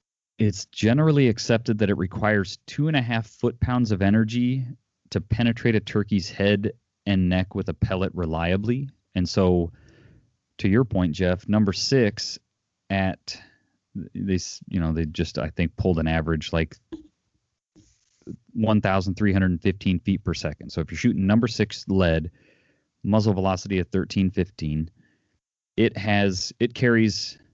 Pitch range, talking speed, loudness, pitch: 95-110 Hz, 140 wpm, -24 LUFS, 100 Hz